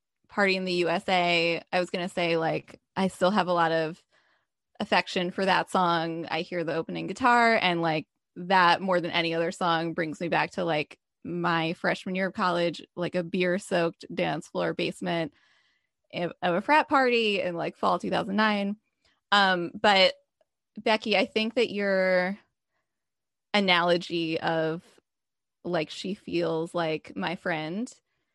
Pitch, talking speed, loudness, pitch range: 180 Hz, 155 wpm, -26 LUFS, 170-200 Hz